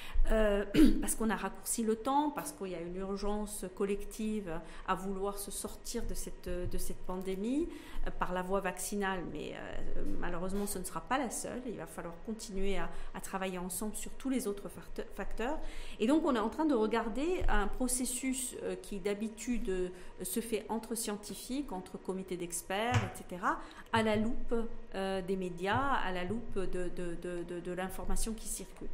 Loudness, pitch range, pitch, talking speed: -36 LUFS, 185-225 Hz, 200 Hz, 180 wpm